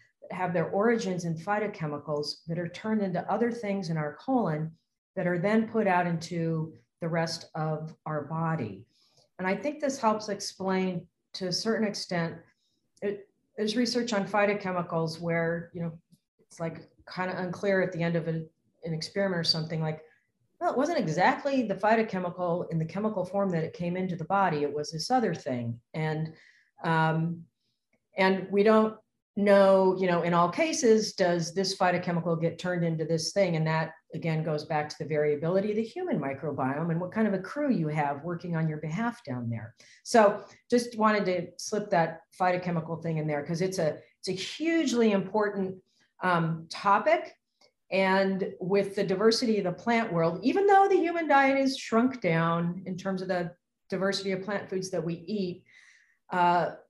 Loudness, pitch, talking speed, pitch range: -28 LUFS, 180 Hz, 180 wpm, 165-205 Hz